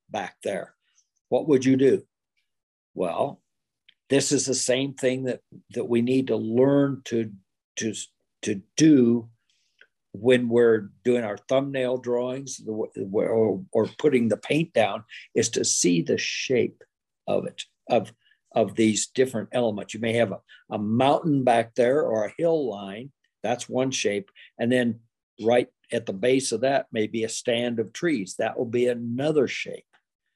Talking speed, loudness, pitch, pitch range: 160 wpm, -24 LUFS, 120 Hz, 110-130 Hz